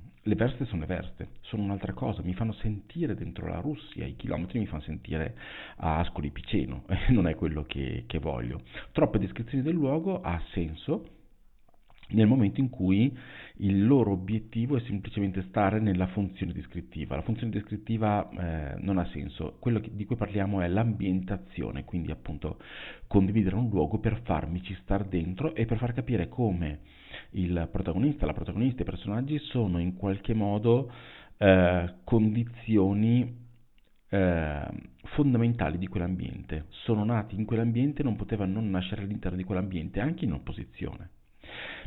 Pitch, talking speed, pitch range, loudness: 100 Hz, 150 wpm, 90-115 Hz, -30 LUFS